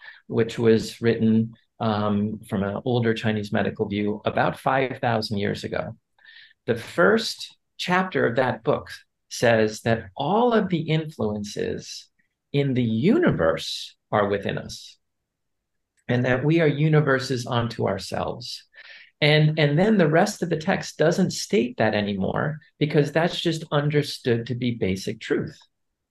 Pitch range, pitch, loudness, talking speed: 110-155 Hz, 125 Hz, -23 LUFS, 135 wpm